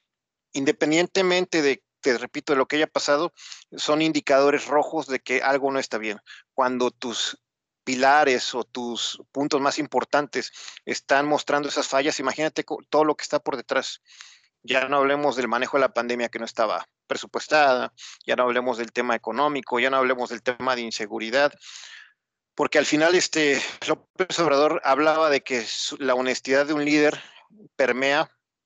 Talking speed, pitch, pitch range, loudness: 160 wpm, 140 Hz, 125-150 Hz, -23 LUFS